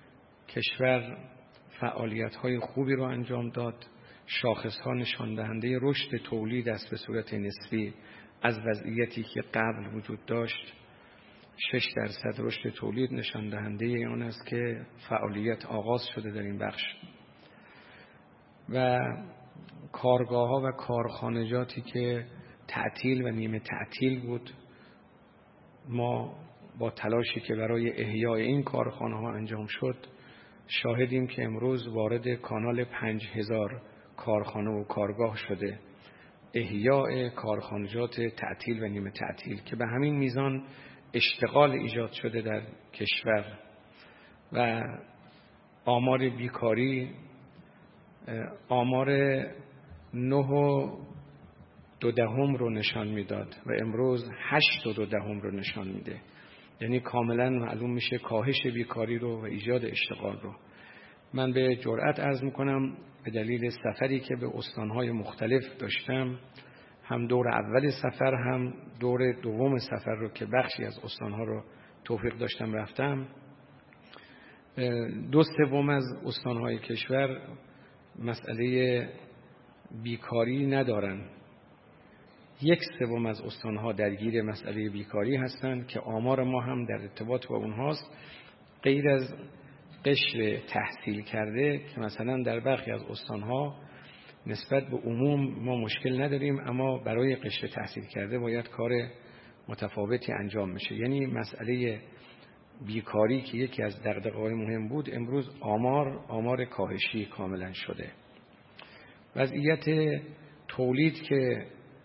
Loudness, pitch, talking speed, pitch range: -31 LUFS, 120 Hz, 115 wpm, 110-130 Hz